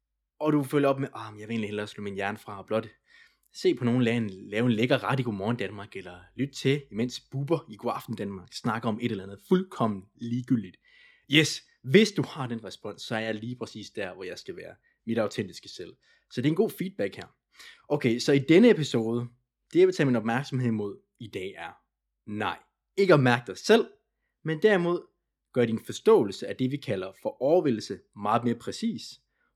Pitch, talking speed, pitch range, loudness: 120 Hz, 215 wpm, 110-145 Hz, -27 LUFS